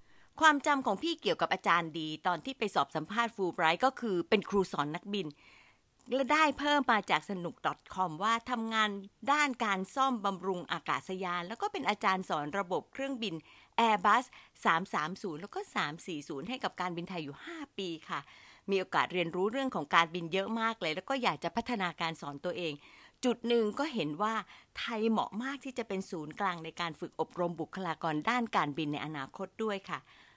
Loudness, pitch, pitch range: -33 LUFS, 195 Hz, 170-240 Hz